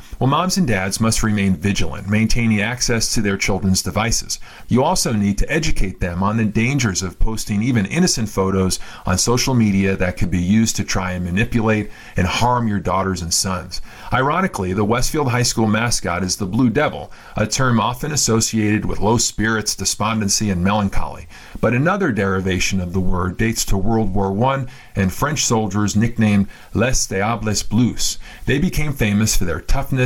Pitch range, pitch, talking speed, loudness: 95-115 Hz, 105 Hz, 175 wpm, -18 LUFS